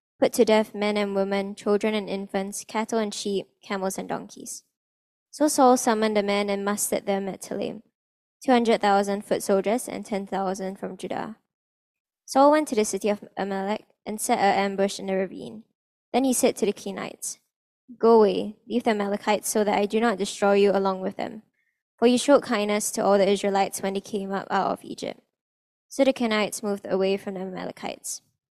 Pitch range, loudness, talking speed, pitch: 195-225 Hz, -24 LUFS, 190 wpm, 205 Hz